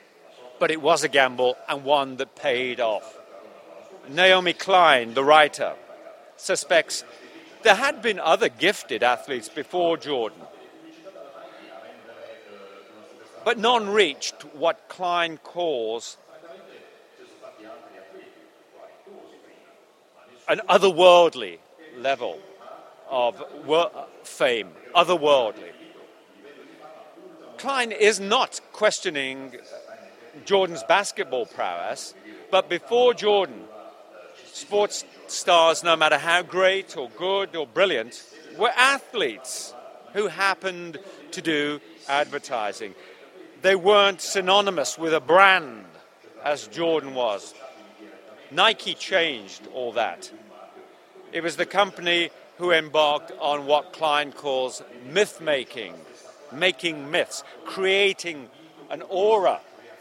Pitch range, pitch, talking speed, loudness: 150-200 Hz, 175 Hz, 95 wpm, -22 LUFS